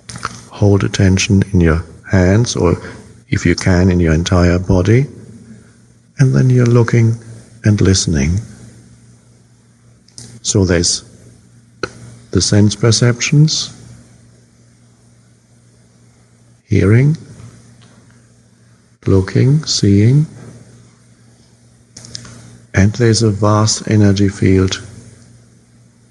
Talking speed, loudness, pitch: 75 wpm, -13 LUFS, 100 Hz